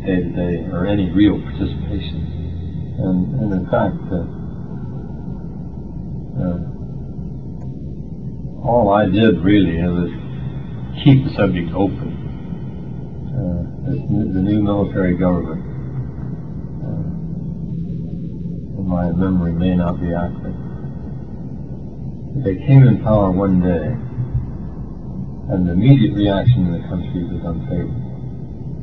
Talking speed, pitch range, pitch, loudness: 105 wpm, 90-130 Hz, 100 Hz, -19 LUFS